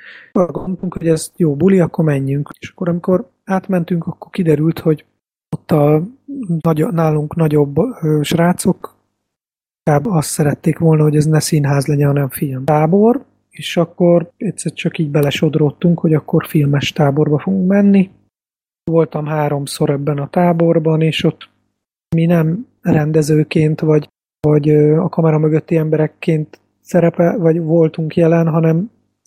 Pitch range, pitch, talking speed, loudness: 150-175 Hz, 160 Hz, 135 wpm, -15 LUFS